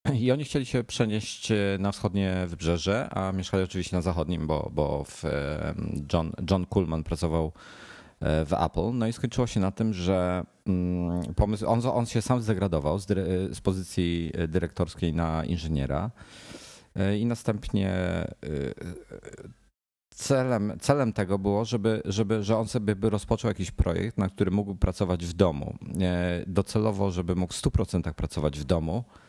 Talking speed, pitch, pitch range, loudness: 145 wpm, 95 Hz, 90-110 Hz, -28 LUFS